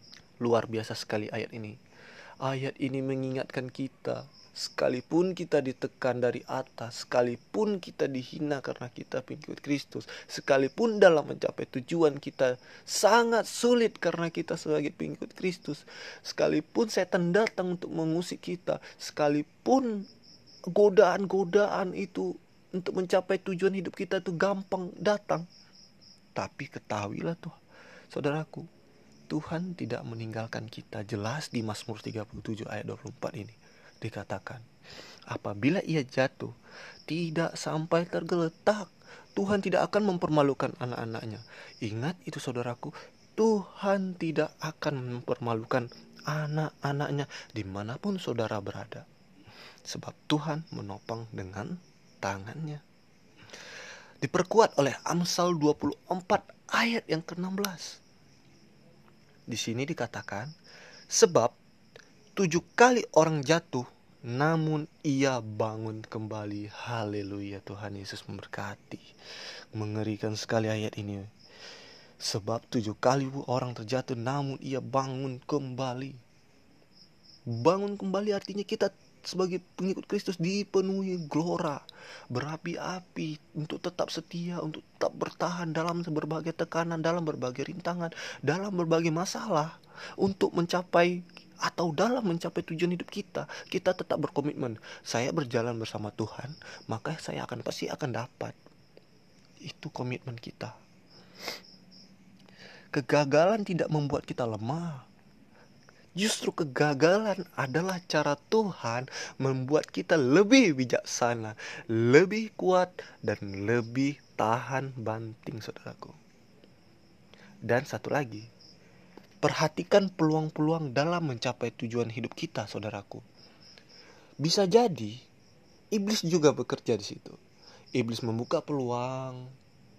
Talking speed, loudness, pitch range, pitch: 100 wpm, -30 LUFS, 120-180 Hz, 150 Hz